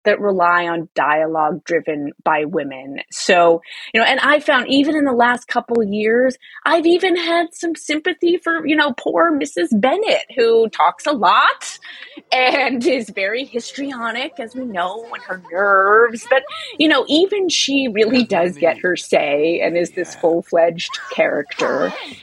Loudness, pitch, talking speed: -17 LUFS, 240 Hz, 160 wpm